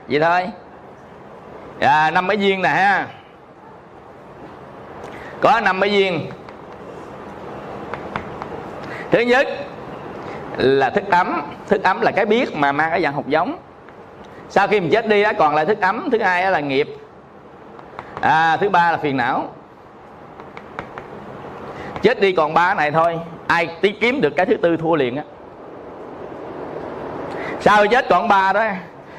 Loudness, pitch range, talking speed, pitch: -17 LUFS, 165-215 Hz, 145 wpm, 190 Hz